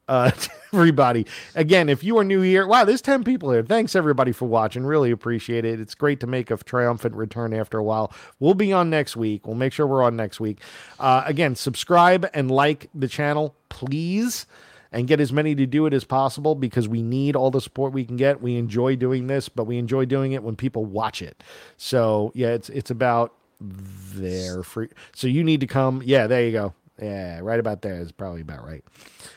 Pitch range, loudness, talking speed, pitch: 115-150 Hz, -22 LUFS, 215 wpm, 130 Hz